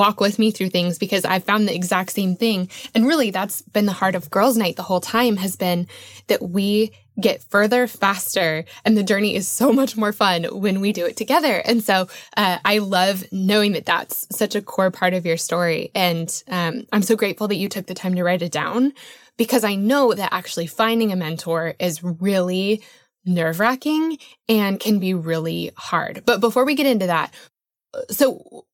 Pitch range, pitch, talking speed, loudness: 180-225 Hz, 200 Hz, 200 wpm, -20 LUFS